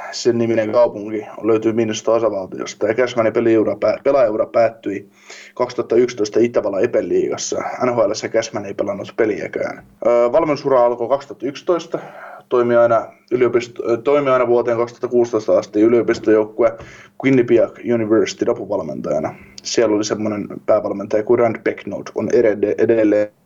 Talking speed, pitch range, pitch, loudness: 105 wpm, 110-145 Hz, 120 Hz, -18 LUFS